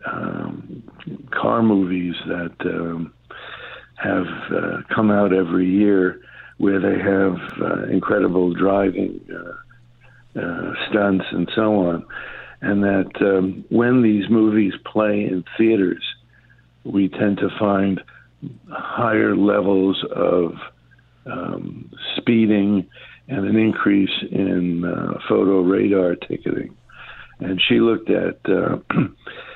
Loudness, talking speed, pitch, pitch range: -19 LUFS, 110 wpm, 100 Hz, 95-110 Hz